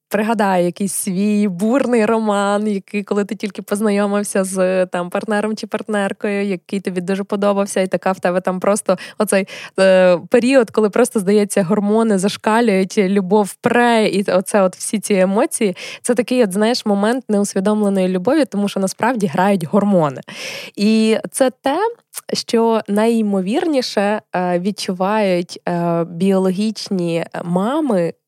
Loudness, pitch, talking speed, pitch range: -17 LUFS, 205 Hz, 130 wpm, 190-220 Hz